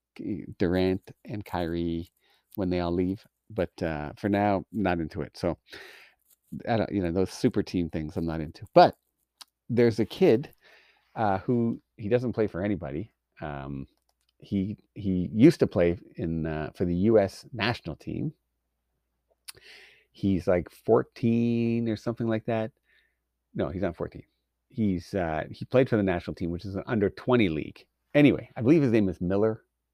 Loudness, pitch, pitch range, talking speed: -27 LUFS, 95 Hz, 85-110 Hz, 165 wpm